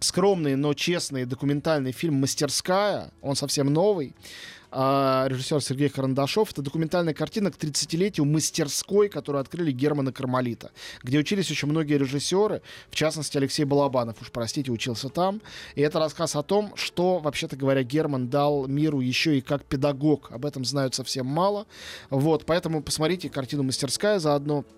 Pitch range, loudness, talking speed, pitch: 135-160 Hz, -25 LUFS, 150 wpm, 145 Hz